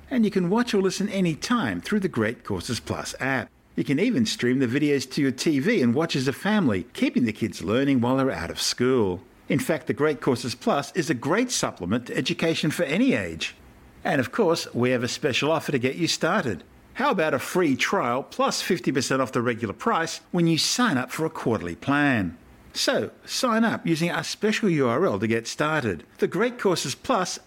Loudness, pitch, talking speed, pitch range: -24 LUFS, 155 Hz, 210 wpm, 130-195 Hz